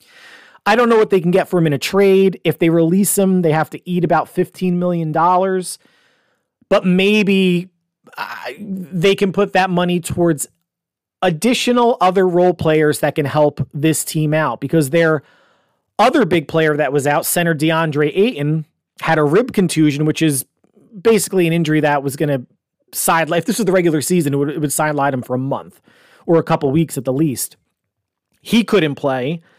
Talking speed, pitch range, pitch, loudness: 190 wpm, 155-190 Hz, 165 Hz, -16 LUFS